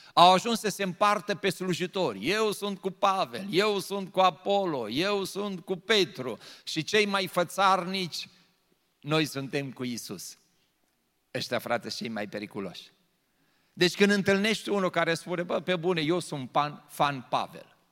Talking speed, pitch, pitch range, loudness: 150 wpm, 185 Hz, 155-195 Hz, -28 LUFS